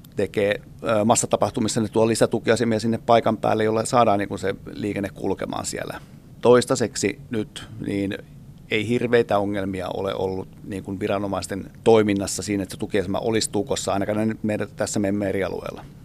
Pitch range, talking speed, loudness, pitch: 100-115 Hz, 140 wpm, -23 LUFS, 110 Hz